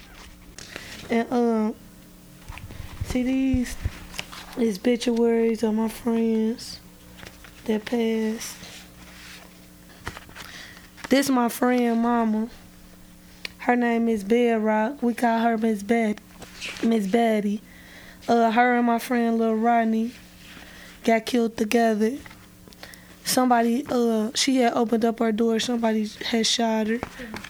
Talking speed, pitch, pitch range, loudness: 110 wpm, 230 Hz, 220-235 Hz, -23 LUFS